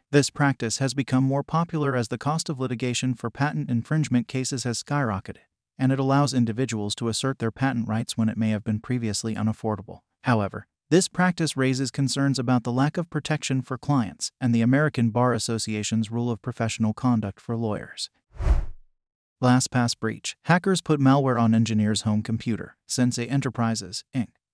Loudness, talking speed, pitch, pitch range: -25 LUFS, 165 wpm, 125 Hz, 110-135 Hz